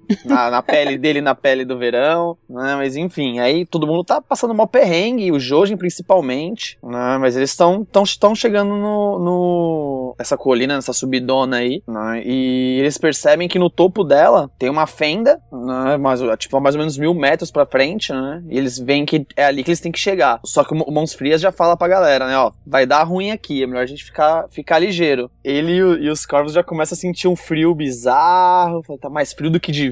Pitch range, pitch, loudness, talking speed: 135-175 Hz, 155 Hz, -16 LUFS, 220 wpm